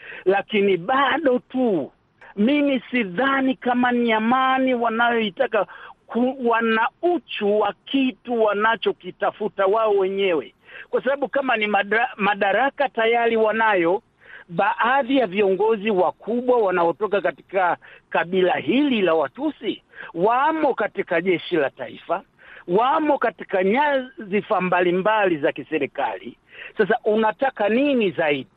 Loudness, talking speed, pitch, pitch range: -21 LUFS, 100 wpm, 225 Hz, 200-260 Hz